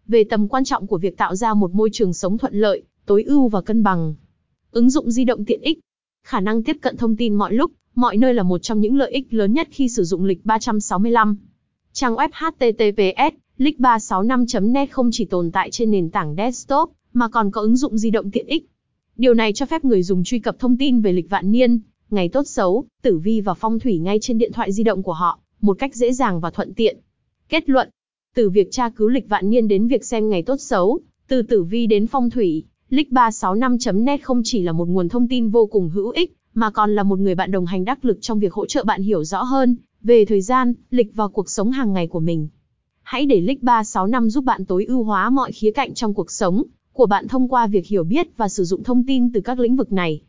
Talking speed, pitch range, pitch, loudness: 235 wpm, 200-250 Hz, 225 Hz, -19 LUFS